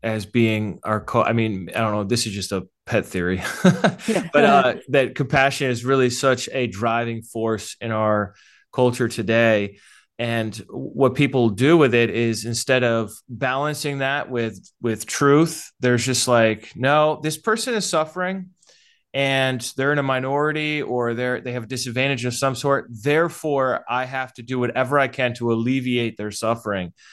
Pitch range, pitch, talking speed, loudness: 115-140 Hz, 125 Hz, 170 wpm, -21 LUFS